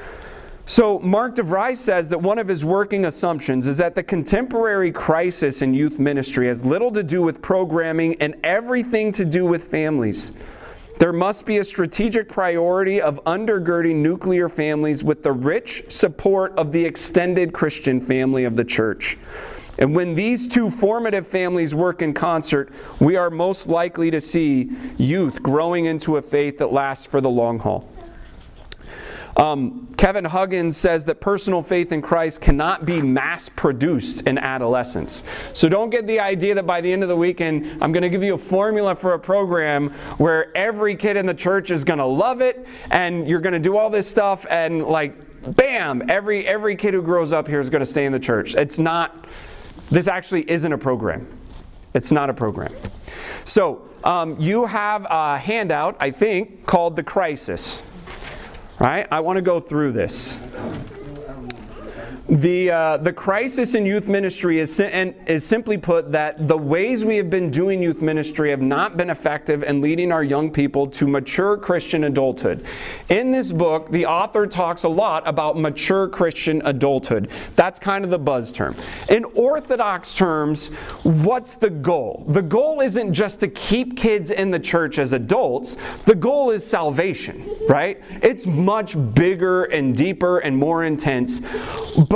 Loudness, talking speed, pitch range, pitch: -20 LUFS, 175 wpm, 150-195 Hz, 170 Hz